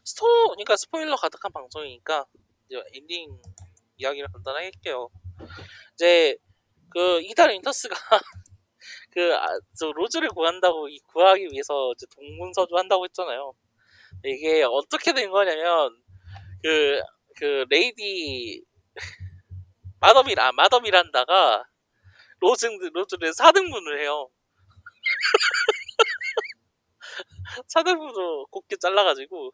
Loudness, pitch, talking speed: -22 LUFS, 190 Hz, 240 characters per minute